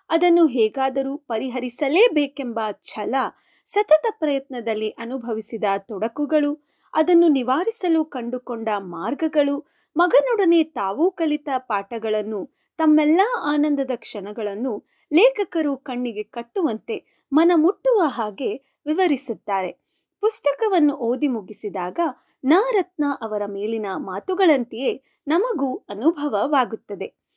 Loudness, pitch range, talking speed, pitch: -22 LUFS, 225-330 Hz, 75 wpm, 280 Hz